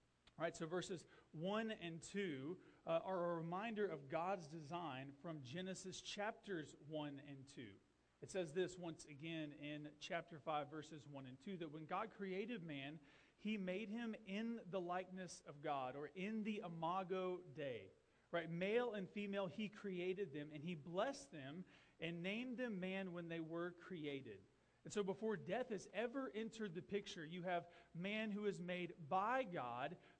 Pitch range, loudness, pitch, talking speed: 160-200 Hz, -48 LUFS, 180 Hz, 170 wpm